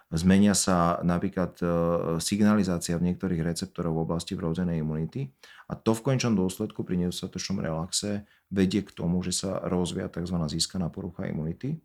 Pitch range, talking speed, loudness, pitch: 85-100 Hz, 145 wpm, -28 LUFS, 90 Hz